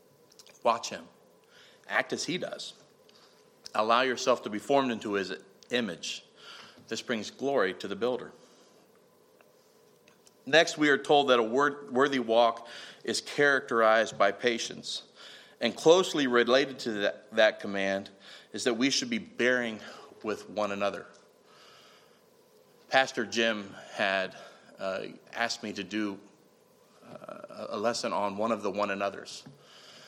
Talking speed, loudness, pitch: 130 wpm, -29 LUFS, 125 Hz